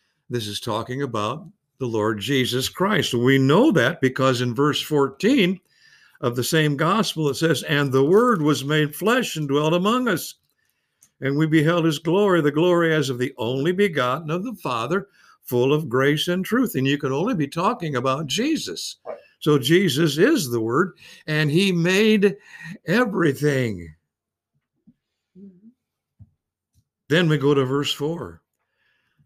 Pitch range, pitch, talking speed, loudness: 135-180 Hz, 155 Hz, 150 wpm, -21 LUFS